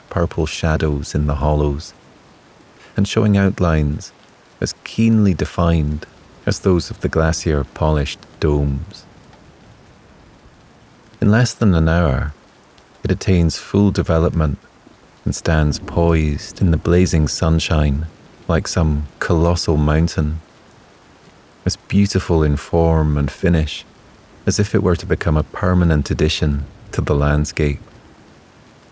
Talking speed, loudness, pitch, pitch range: 115 wpm, -18 LUFS, 80 Hz, 75-95 Hz